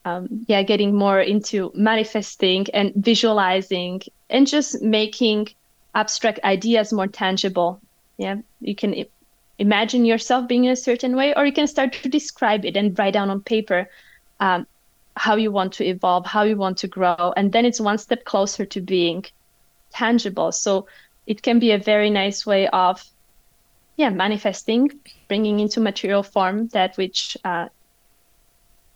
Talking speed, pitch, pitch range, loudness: 155 wpm, 205 Hz, 190-225 Hz, -20 LUFS